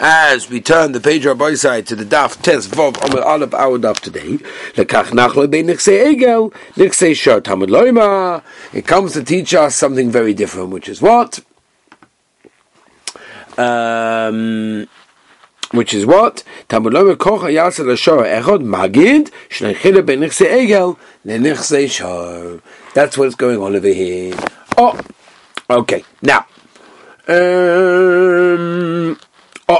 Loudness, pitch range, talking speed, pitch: -13 LUFS, 115-180 Hz, 125 wpm, 150 Hz